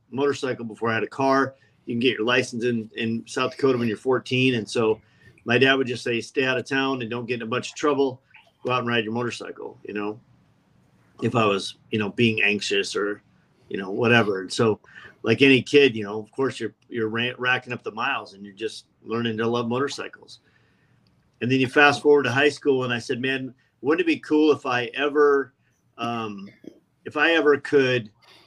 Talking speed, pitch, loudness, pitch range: 215 wpm, 125 Hz, -23 LUFS, 115-135 Hz